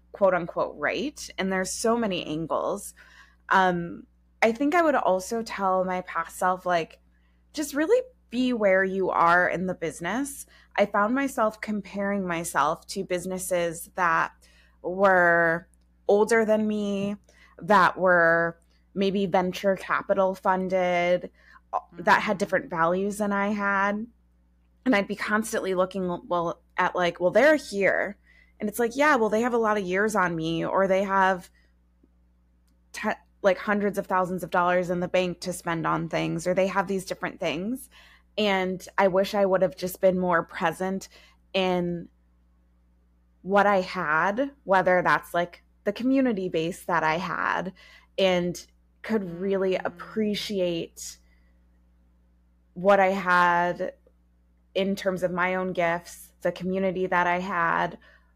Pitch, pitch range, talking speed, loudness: 185 Hz, 170-200 Hz, 145 wpm, -25 LUFS